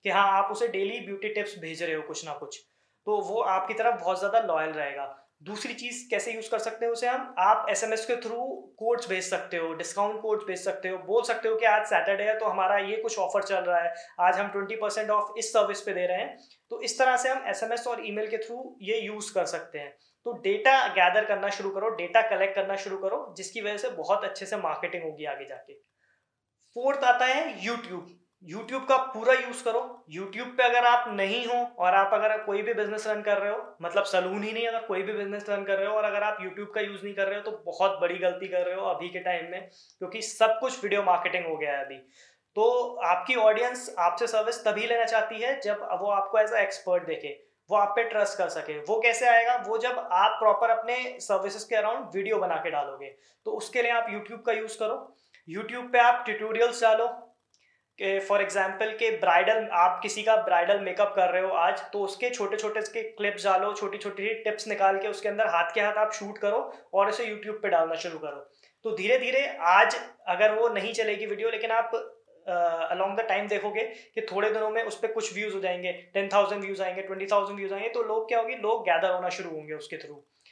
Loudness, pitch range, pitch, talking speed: -27 LUFS, 190-230 Hz, 210 Hz, 230 wpm